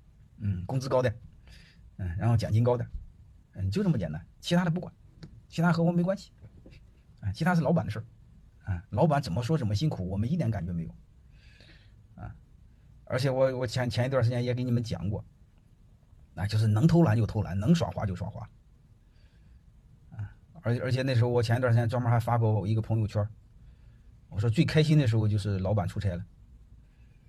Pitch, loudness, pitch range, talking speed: 110 Hz, -28 LUFS, 100-125 Hz, 285 characters per minute